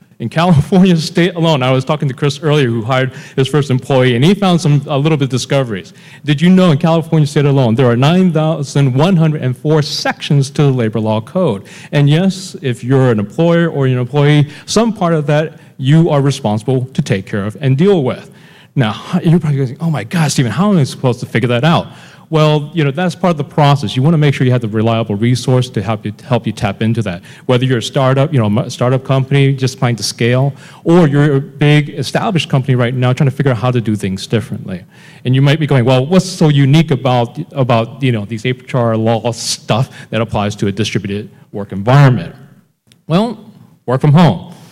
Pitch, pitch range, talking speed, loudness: 140 Hz, 125-160 Hz, 225 wpm, -13 LUFS